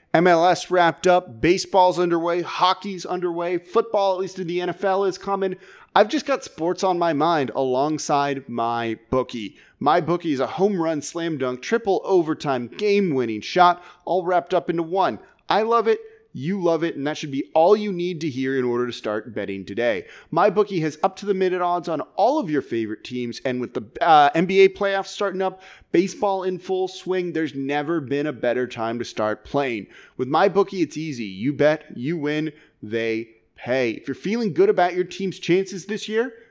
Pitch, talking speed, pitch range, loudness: 175 Hz, 195 wpm, 135-190 Hz, -22 LUFS